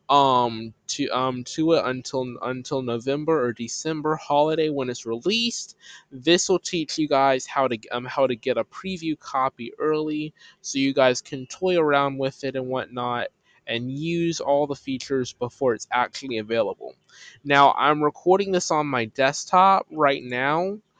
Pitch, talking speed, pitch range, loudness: 135 Hz, 165 wpm, 125-155 Hz, -23 LUFS